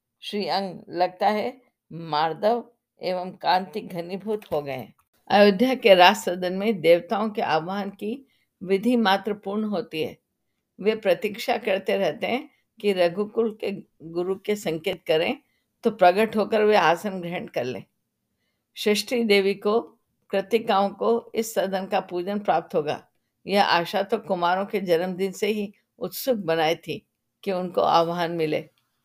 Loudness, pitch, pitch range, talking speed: -24 LUFS, 200 Hz, 180-215 Hz, 145 wpm